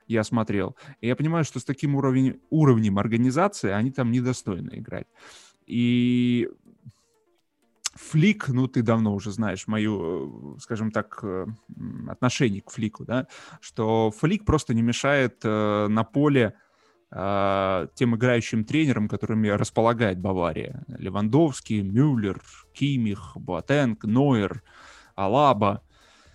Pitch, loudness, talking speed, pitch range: 115 Hz, -24 LUFS, 115 wpm, 105-130 Hz